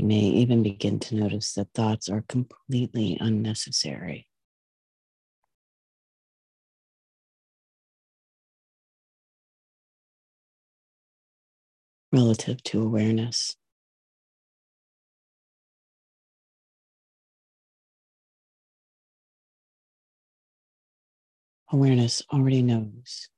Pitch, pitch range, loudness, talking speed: 110 Hz, 105-125 Hz, -25 LUFS, 40 wpm